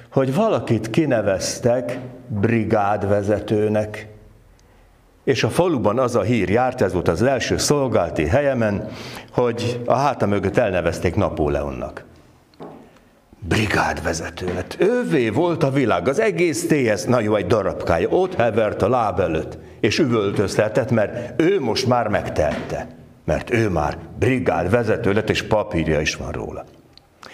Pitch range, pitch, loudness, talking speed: 95-120 Hz, 105 Hz, -20 LUFS, 125 wpm